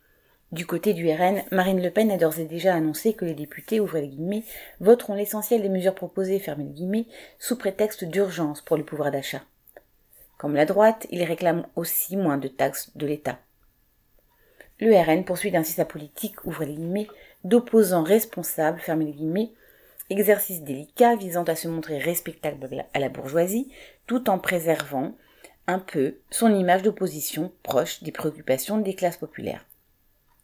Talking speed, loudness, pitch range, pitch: 160 wpm, -25 LUFS, 155-200 Hz, 175 Hz